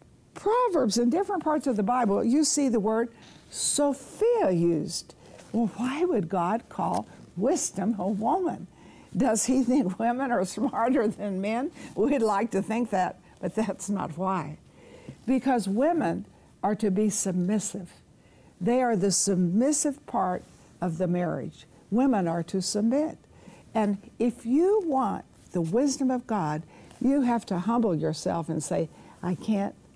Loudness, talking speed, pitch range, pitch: -27 LUFS, 145 wpm, 190-260 Hz, 220 Hz